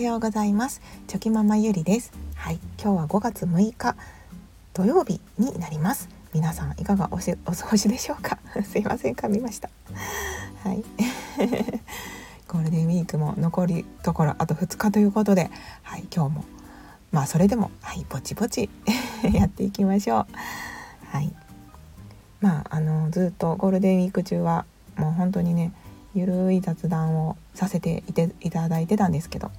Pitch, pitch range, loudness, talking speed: 185 Hz, 165-210 Hz, -25 LUFS, 320 characters per minute